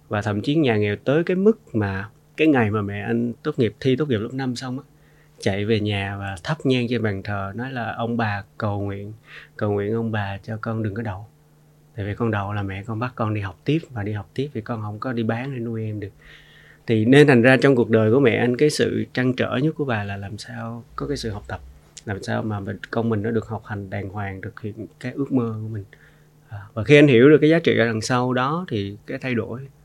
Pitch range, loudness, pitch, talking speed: 105-135 Hz, -22 LUFS, 115 Hz, 265 wpm